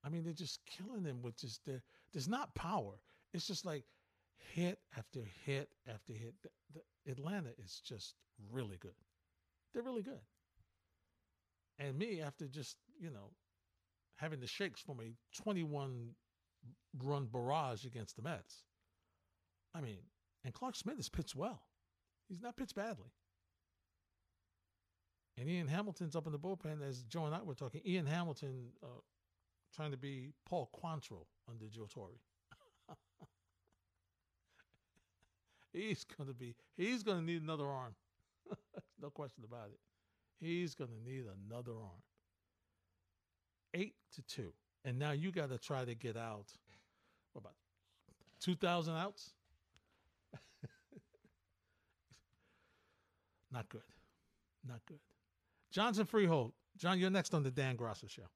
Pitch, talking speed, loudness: 120 Hz, 140 wpm, -44 LUFS